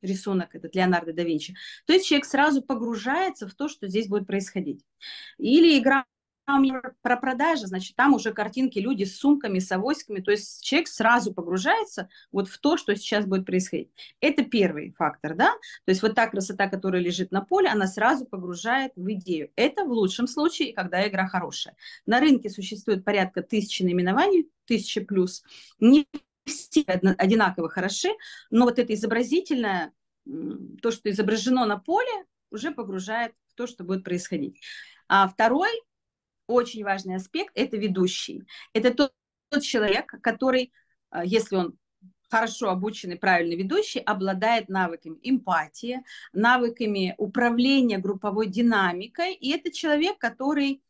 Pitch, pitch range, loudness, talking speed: 225 Hz, 195-275 Hz, -25 LUFS, 145 wpm